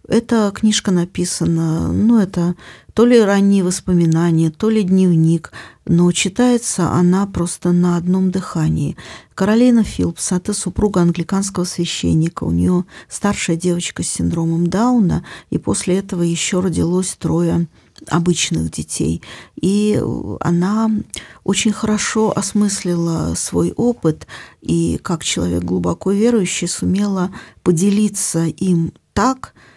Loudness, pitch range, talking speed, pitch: -17 LUFS, 165-205 Hz, 115 wpm, 180 Hz